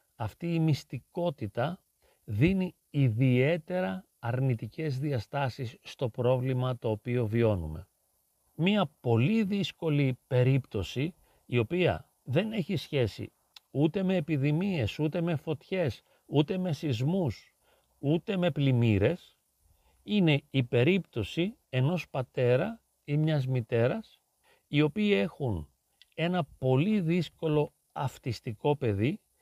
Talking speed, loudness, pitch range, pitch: 100 wpm, -30 LUFS, 125-175 Hz, 145 Hz